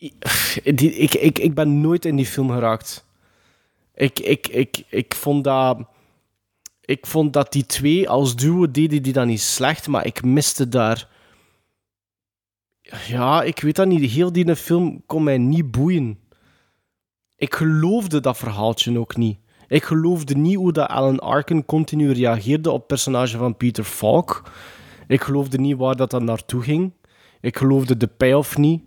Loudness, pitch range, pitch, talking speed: -19 LUFS, 120-155 Hz, 135 Hz, 160 wpm